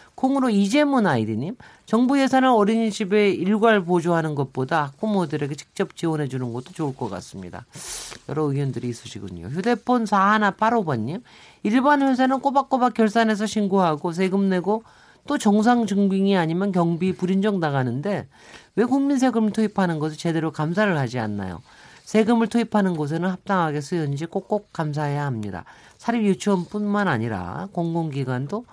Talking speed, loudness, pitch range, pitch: 365 characters per minute, -22 LUFS, 150-220 Hz, 190 Hz